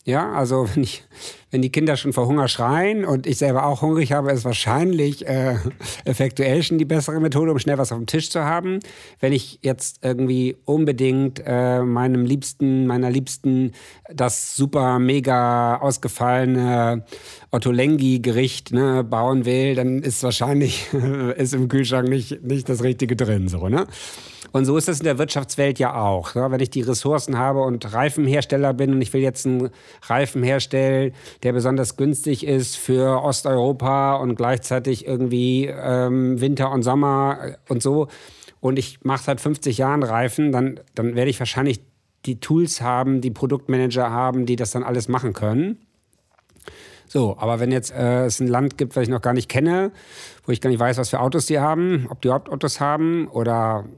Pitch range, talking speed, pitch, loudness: 125-140 Hz, 175 wpm, 130 Hz, -21 LUFS